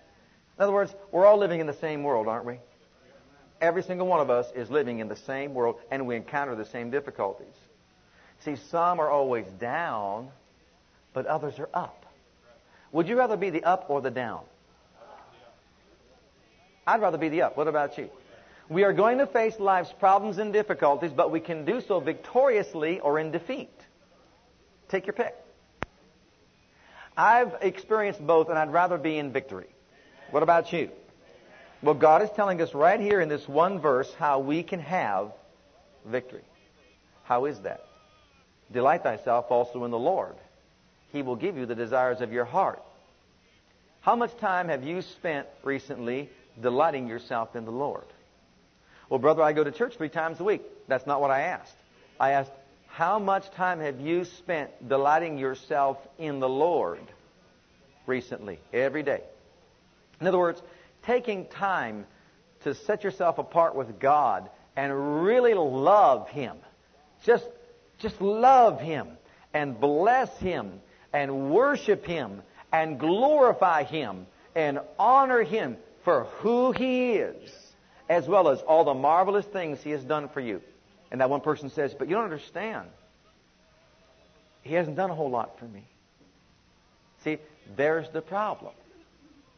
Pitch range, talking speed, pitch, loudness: 140-195 Hz, 155 wpm, 160 Hz, -26 LUFS